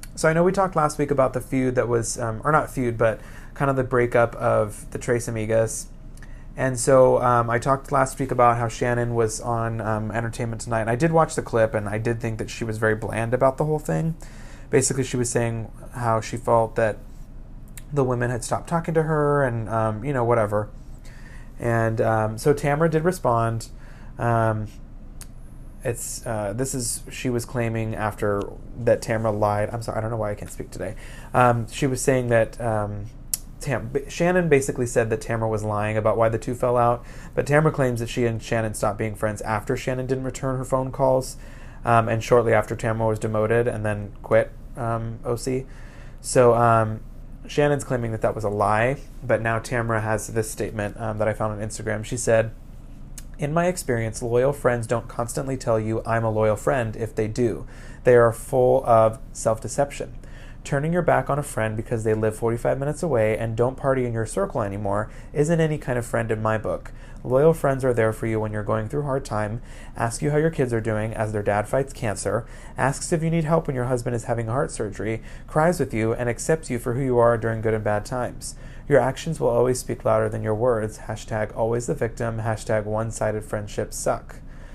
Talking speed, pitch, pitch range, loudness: 210 wpm, 120 Hz, 110-130 Hz, -23 LUFS